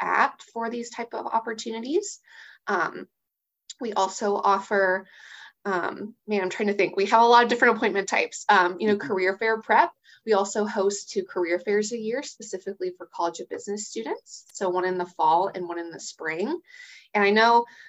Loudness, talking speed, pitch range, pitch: -24 LUFS, 190 wpm, 190-235 Hz, 210 Hz